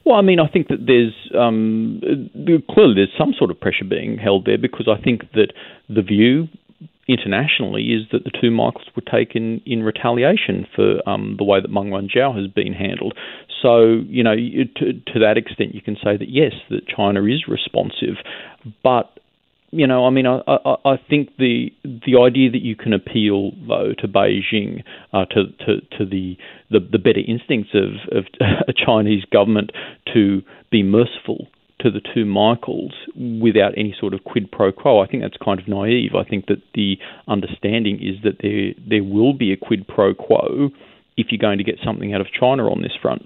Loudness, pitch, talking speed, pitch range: -18 LUFS, 115 Hz, 195 wpm, 105-125 Hz